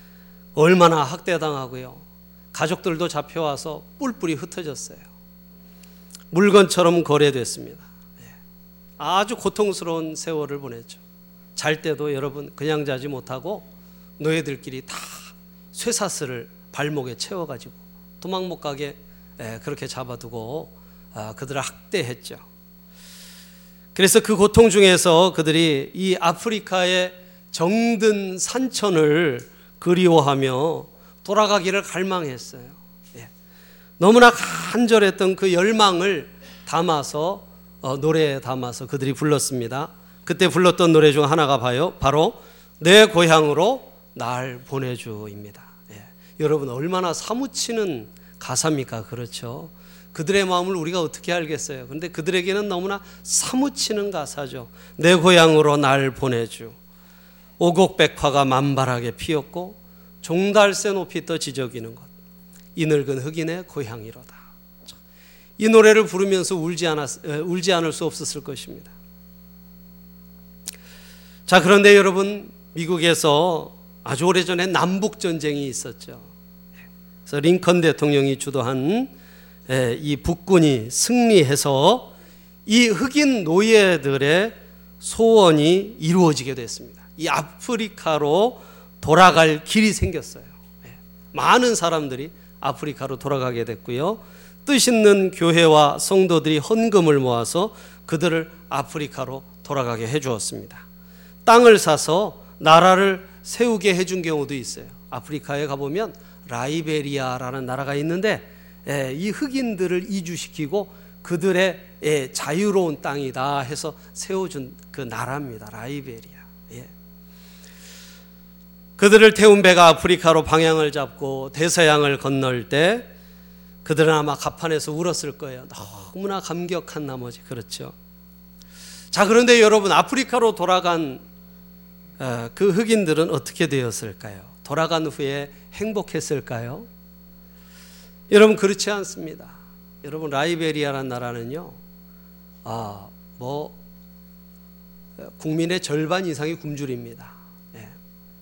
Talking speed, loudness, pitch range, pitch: 260 characters per minute, -19 LUFS, 130-180 Hz, 160 Hz